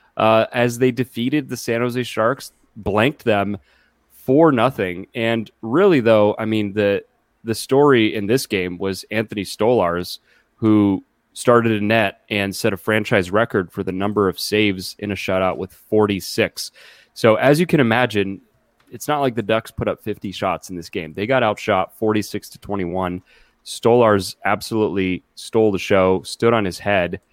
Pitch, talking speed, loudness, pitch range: 105 Hz, 170 wpm, -19 LUFS, 95-115 Hz